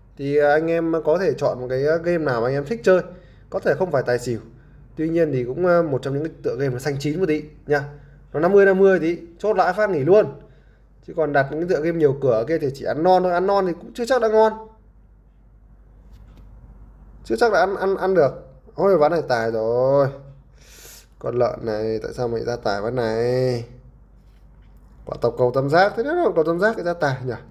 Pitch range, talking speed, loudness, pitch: 130-180 Hz, 230 wpm, -20 LUFS, 150 Hz